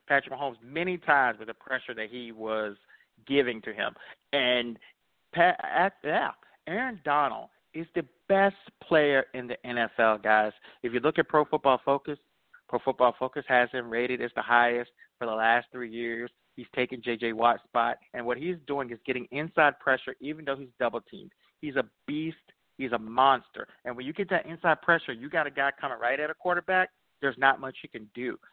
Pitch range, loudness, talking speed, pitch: 120-155 Hz, -28 LUFS, 195 wpm, 130 Hz